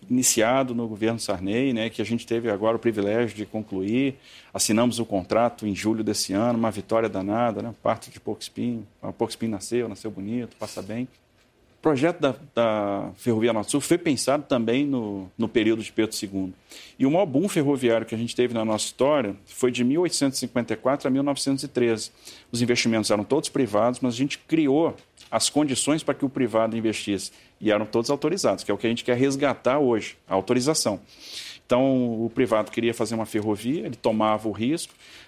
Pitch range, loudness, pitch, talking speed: 110-125 Hz, -24 LUFS, 115 Hz, 190 wpm